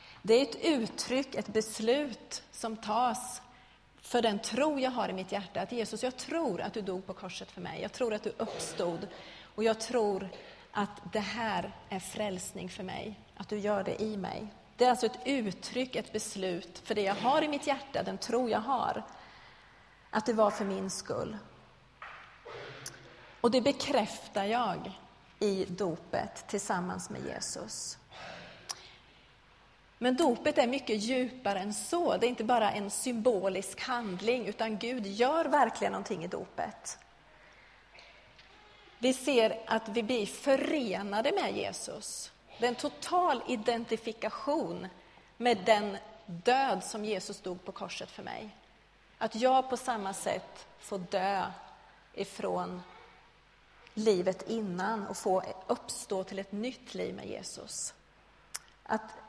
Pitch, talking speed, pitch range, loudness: 220 Hz, 145 wpm, 200-250 Hz, -33 LUFS